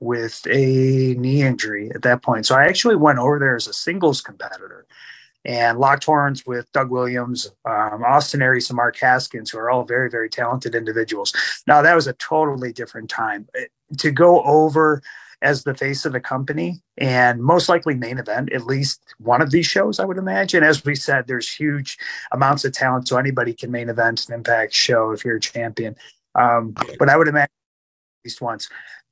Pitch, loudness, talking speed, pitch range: 130 Hz, -18 LUFS, 195 wpm, 120-145 Hz